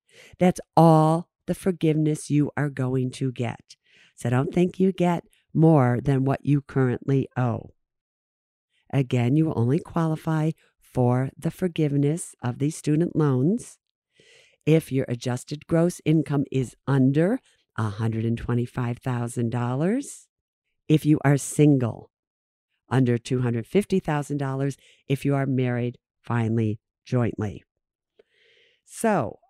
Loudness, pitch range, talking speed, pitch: -24 LUFS, 125-160 Hz, 110 wpm, 140 Hz